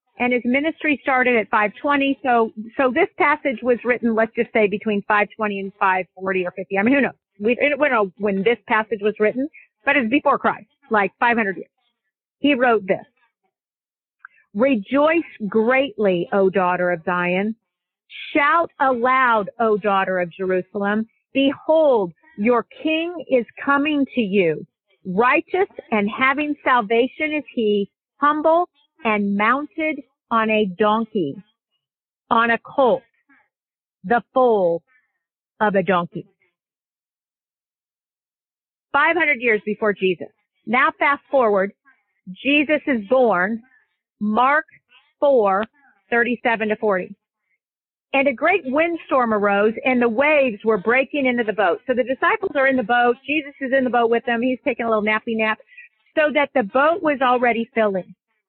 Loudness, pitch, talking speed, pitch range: -19 LUFS, 240 Hz, 145 wpm, 210-280 Hz